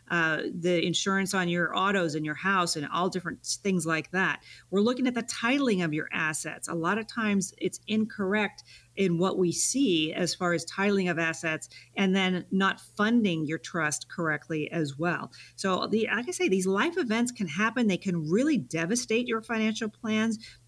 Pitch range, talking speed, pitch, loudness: 165-220 Hz, 190 wpm, 185 Hz, -28 LUFS